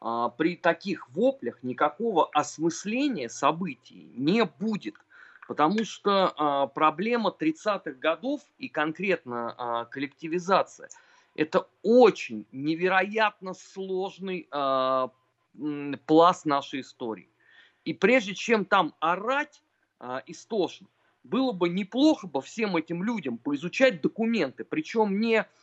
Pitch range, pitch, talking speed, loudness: 145-225 Hz, 180 Hz, 95 wpm, -27 LUFS